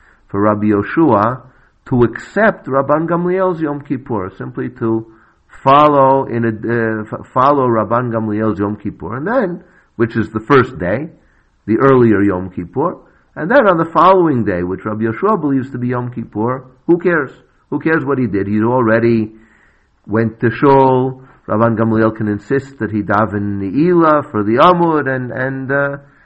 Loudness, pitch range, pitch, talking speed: -15 LUFS, 110-145 Hz, 120 Hz, 165 wpm